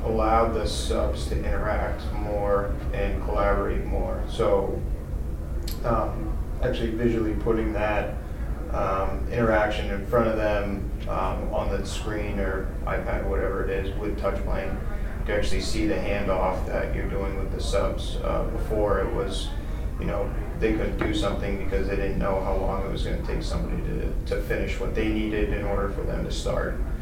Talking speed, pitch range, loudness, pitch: 170 wpm, 95-105 Hz, -27 LUFS, 100 Hz